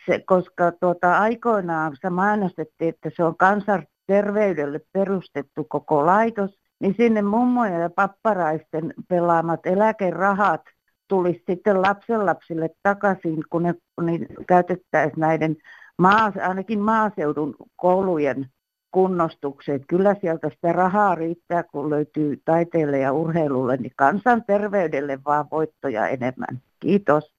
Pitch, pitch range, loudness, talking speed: 175 Hz, 155-200 Hz, -22 LUFS, 110 wpm